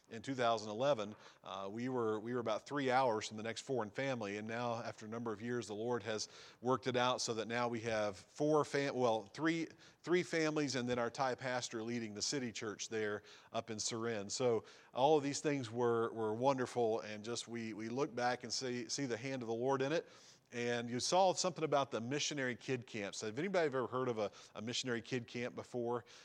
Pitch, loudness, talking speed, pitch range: 120 Hz, -39 LUFS, 220 wpm, 115-135 Hz